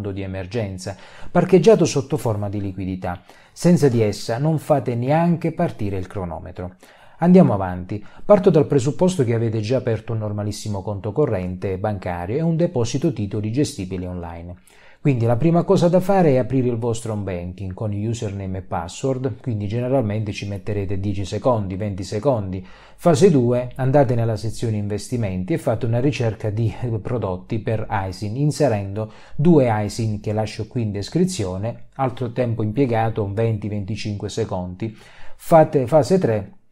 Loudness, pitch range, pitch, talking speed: -21 LUFS, 100-140 Hz, 110 Hz, 145 wpm